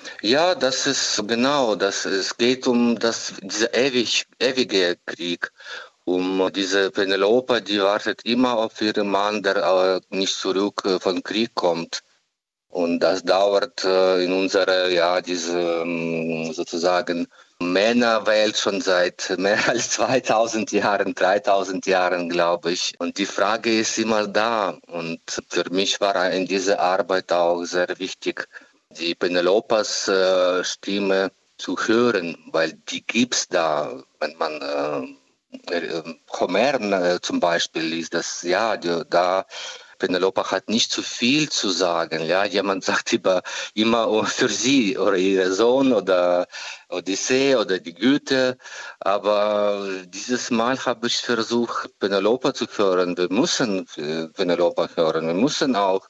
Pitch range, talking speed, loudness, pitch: 90-110 Hz, 130 wpm, -21 LUFS, 95 Hz